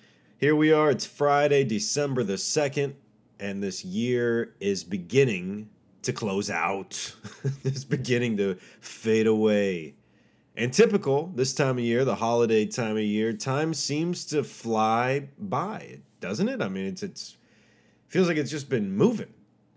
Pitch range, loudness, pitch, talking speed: 110-150 Hz, -26 LUFS, 130 Hz, 150 wpm